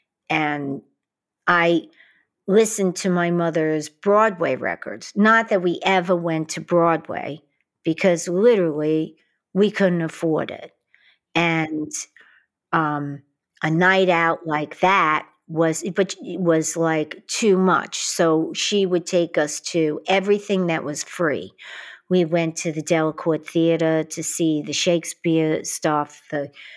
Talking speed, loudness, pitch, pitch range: 130 wpm, -21 LUFS, 165 Hz, 155-180 Hz